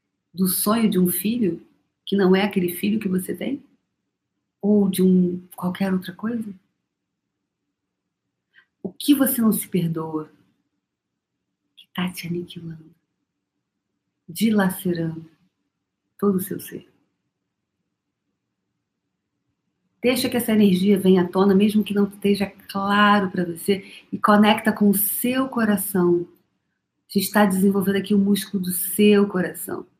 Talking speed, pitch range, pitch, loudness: 125 wpm, 180-210 Hz, 195 Hz, -21 LUFS